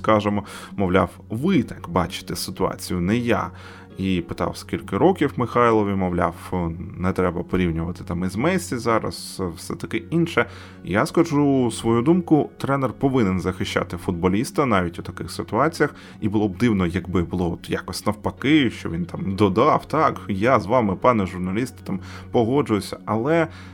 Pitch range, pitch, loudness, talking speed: 90-120 Hz, 100 Hz, -22 LUFS, 145 wpm